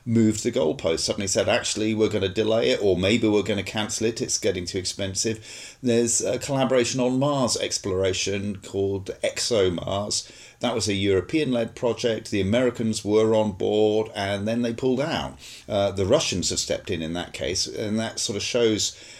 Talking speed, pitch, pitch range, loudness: 190 wpm, 110 Hz, 100-115 Hz, -24 LUFS